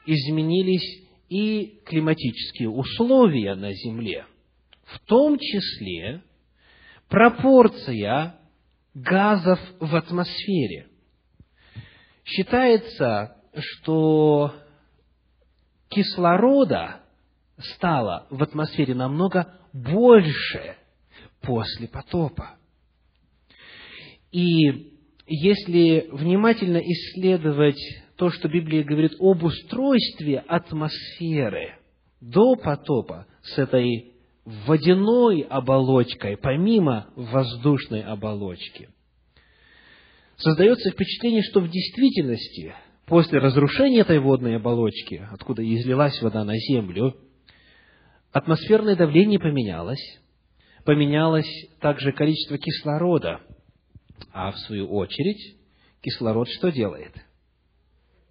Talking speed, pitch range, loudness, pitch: 75 wpm, 115-180 Hz, -21 LUFS, 150 Hz